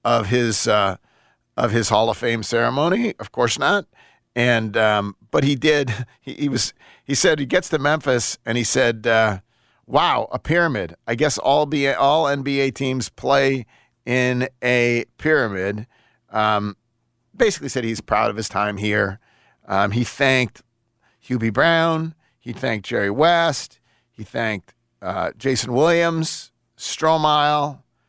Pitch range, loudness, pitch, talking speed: 115-140 Hz, -20 LUFS, 120 Hz, 145 wpm